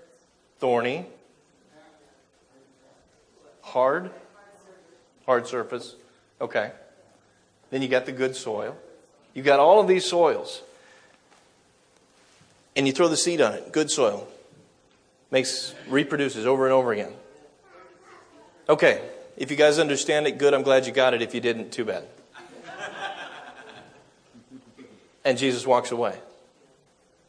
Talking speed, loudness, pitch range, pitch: 115 wpm, -23 LUFS, 130-175 Hz, 140 Hz